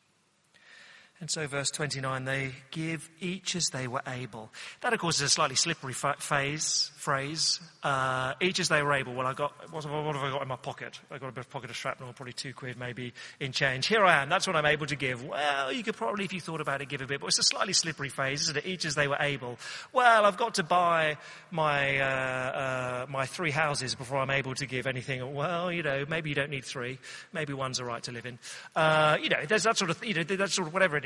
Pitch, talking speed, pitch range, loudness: 145 Hz, 255 wpm, 135-165 Hz, -29 LUFS